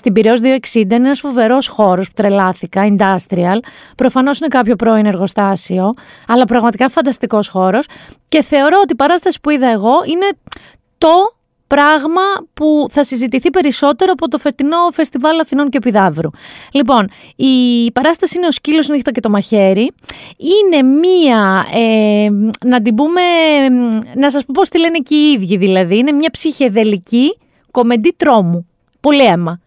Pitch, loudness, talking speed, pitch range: 260 Hz, -12 LUFS, 150 wpm, 220-305 Hz